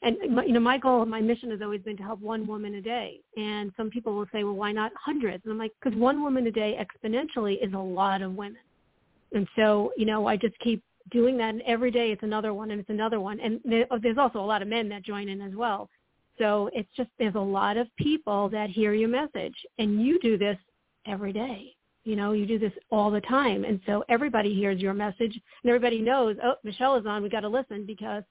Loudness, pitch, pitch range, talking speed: -28 LUFS, 220 Hz, 210-235 Hz, 245 wpm